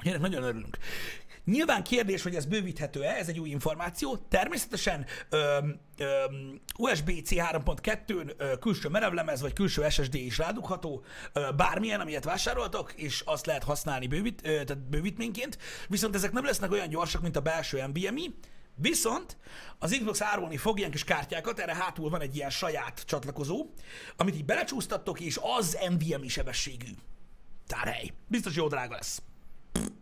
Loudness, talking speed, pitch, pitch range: -32 LUFS, 140 wpm, 165 Hz, 145-205 Hz